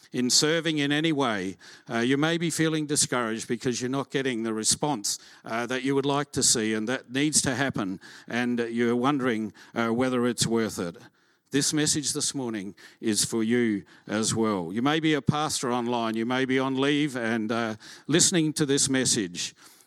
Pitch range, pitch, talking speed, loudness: 115-145 Hz, 130 Hz, 190 wpm, -26 LUFS